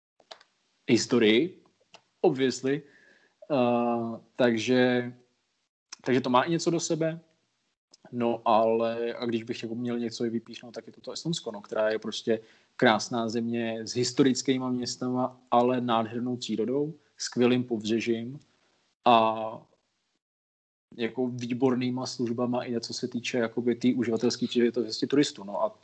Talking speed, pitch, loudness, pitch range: 130 wpm, 120 Hz, -28 LUFS, 115-125 Hz